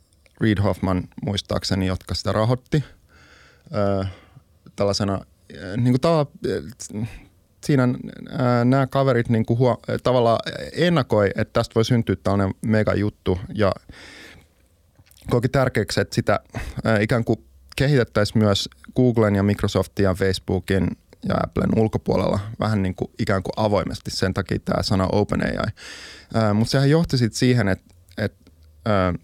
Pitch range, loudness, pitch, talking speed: 95-120 Hz, -22 LUFS, 105 Hz, 140 wpm